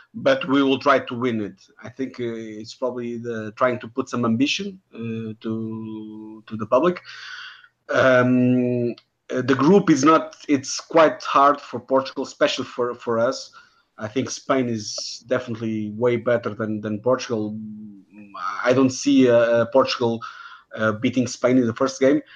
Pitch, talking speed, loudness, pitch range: 125 Hz, 160 wpm, -21 LUFS, 110-135 Hz